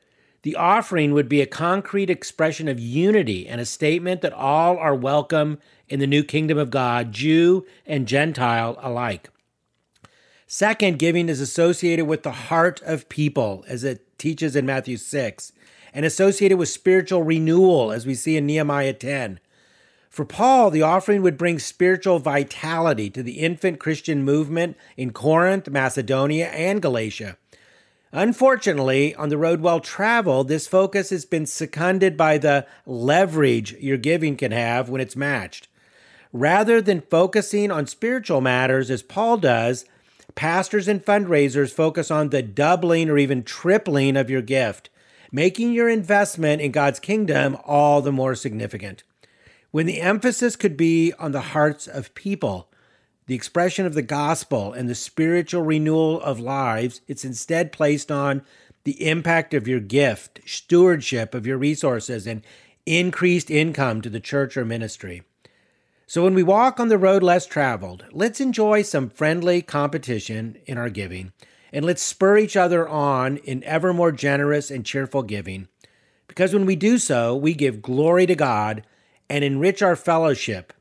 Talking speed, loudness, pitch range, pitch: 155 wpm, -21 LUFS, 130-175 Hz, 150 Hz